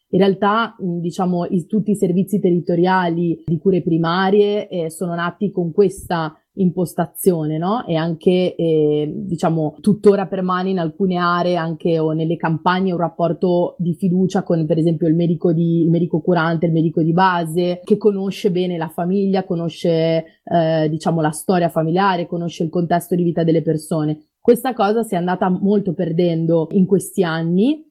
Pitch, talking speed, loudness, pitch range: 175 Hz, 165 wpm, -18 LUFS, 165-190 Hz